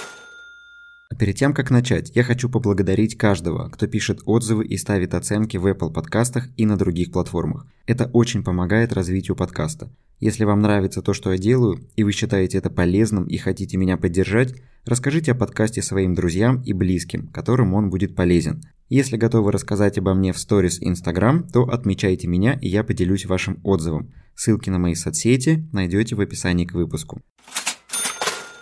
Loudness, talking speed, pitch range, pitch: -21 LUFS, 165 wpm, 95-120 Hz, 105 Hz